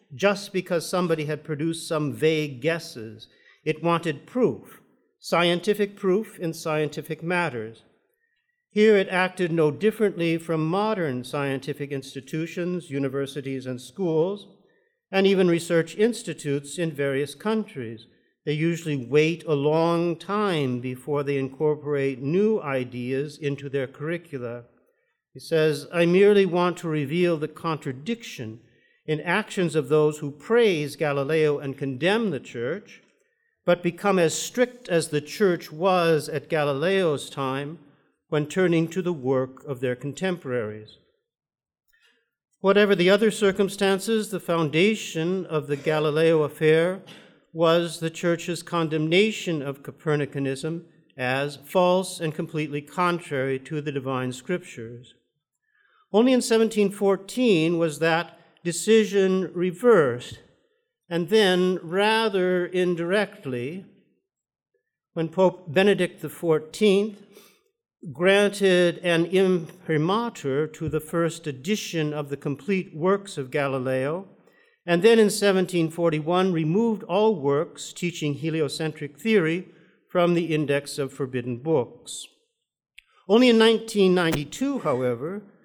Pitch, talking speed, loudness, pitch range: 165 Hz, 115 wpm, -24 LUFS, 145-195 Hz